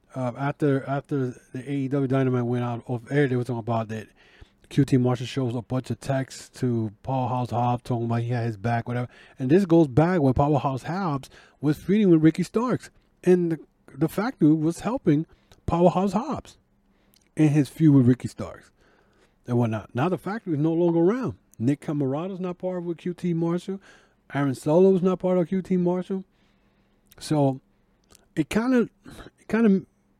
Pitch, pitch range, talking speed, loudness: 145 Hz, 125-180 Hz, 180 wpm, -24 LUFS